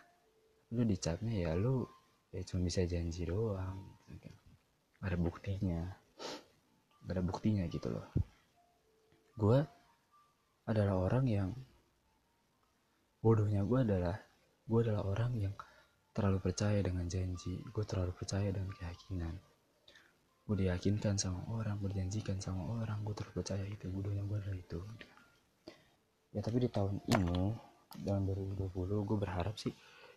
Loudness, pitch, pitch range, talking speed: -38 LUFS, 100 Hz, 90-115 Hz, 120 wpm